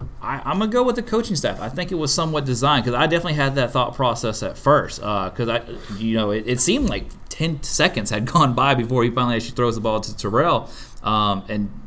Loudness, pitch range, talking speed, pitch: -20 LUFS, 110-150 Hz, 250 wpm, 125 Hz